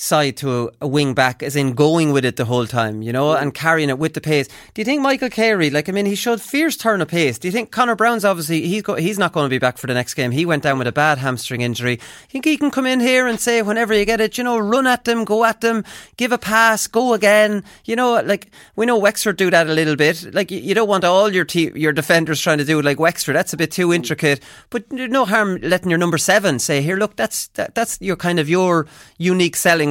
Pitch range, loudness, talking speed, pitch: 150-225 Hz, -17 LUFS, 275 wpm, 180 Hz